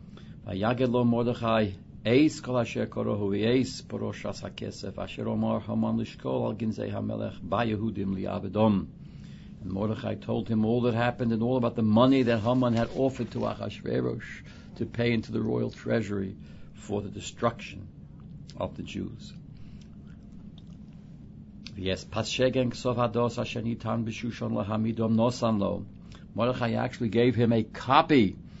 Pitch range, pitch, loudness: 105-120 Hz, 115 Hz, -28 LUFS